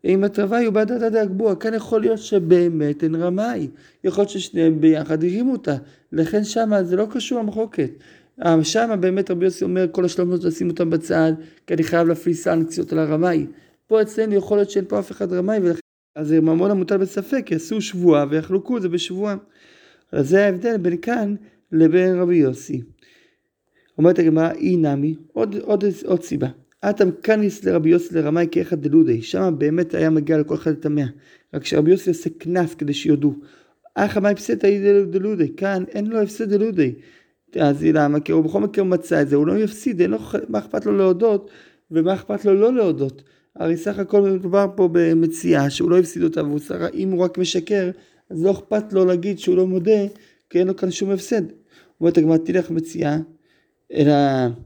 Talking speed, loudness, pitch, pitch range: 185 wpm, -19 LUFS, 180 Hz, 160-205 Hz